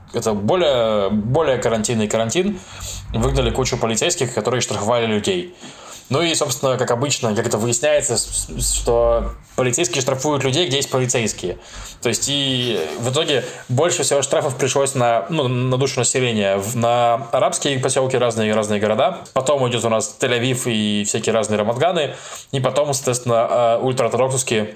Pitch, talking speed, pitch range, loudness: 125 Hz, 145 wpm, 115-135 Hz, -19 LUFS